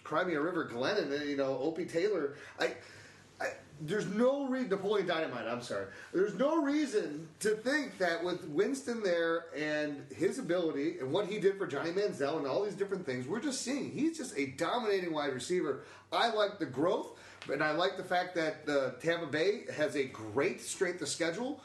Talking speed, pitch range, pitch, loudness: 190 wpm, 155-255 Hz, 180 Hz, -34 LUFS